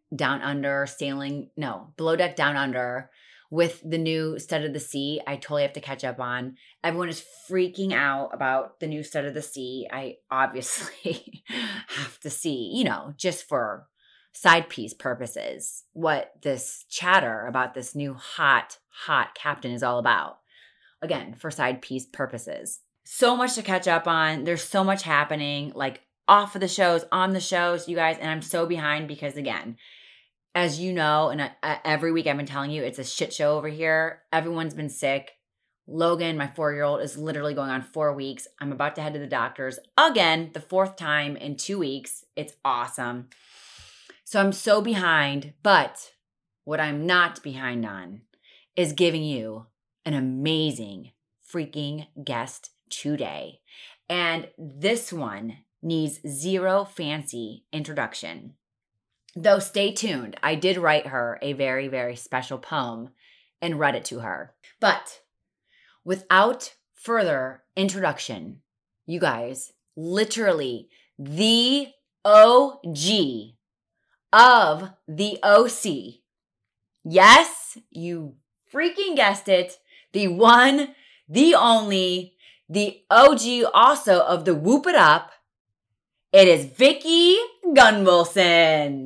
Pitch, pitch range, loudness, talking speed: 155 Hz, 140-185 Hz, -22 LUFS, 140 wpm